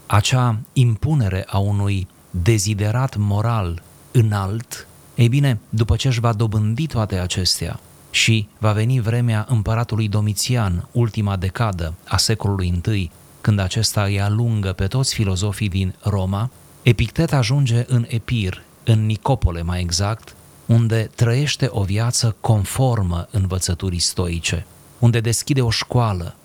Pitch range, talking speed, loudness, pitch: 95-120 Hz, 125 wpm, -20 LUFS, 110 Hz